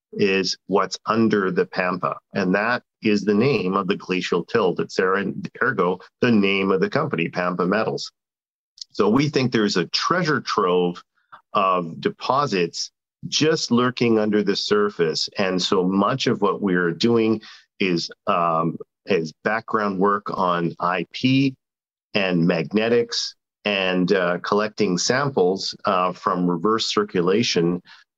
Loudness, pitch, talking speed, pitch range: -21 LUFS, 100 Hz, 135 wpm, 90-110 Hz